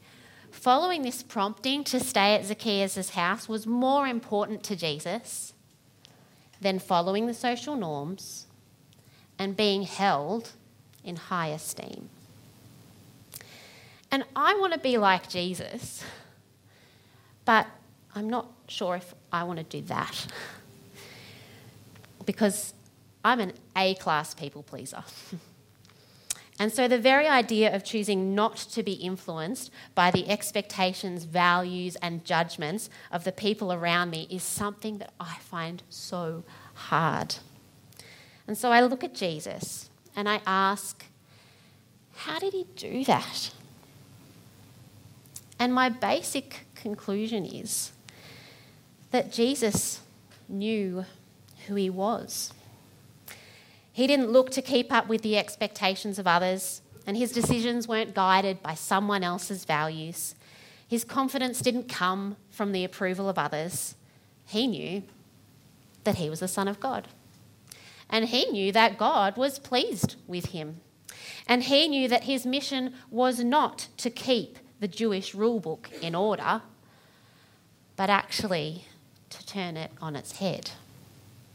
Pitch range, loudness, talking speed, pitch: 160-225 Hz, -28 LUFS, 125 wpm, 195 Hz